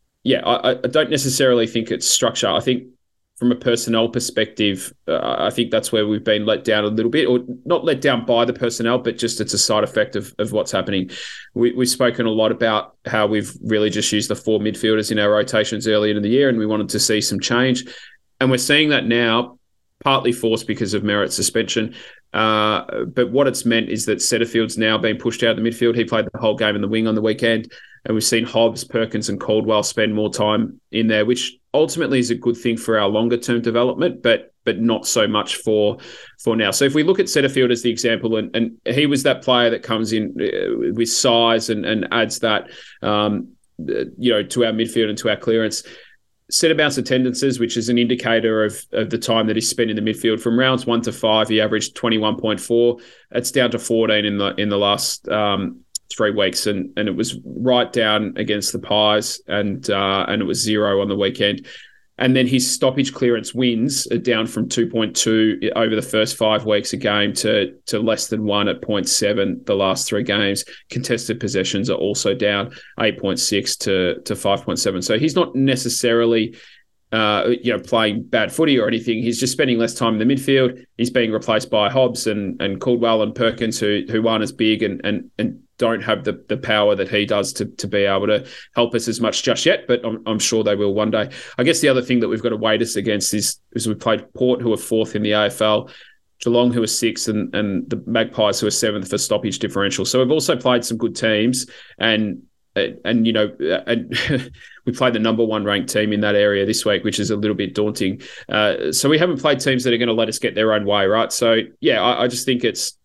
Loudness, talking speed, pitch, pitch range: -19 LUFS, 230 wpm, 115 Hz, 105-120 Hz